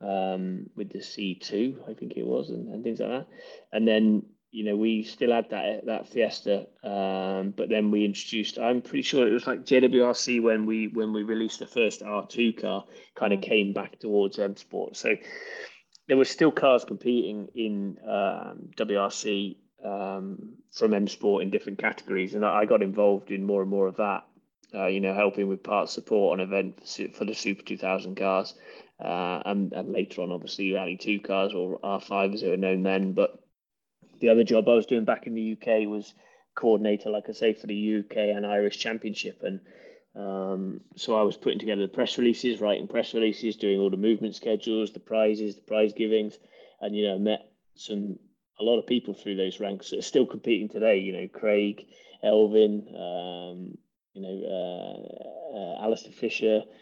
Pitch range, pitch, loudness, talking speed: 100-110 Hz, 105 Hz, -27 LUFS, 195 wpm